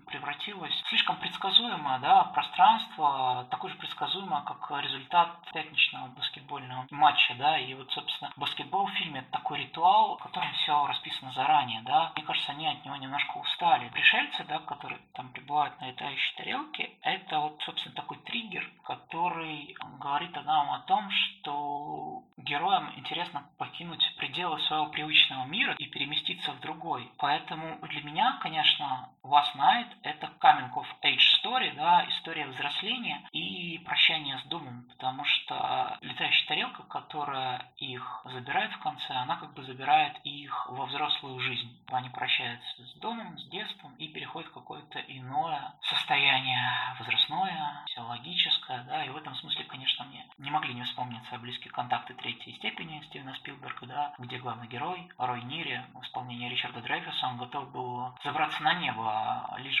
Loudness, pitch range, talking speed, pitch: -29 LUFS, 125-155 Hz, 150 wpm, 145 Hz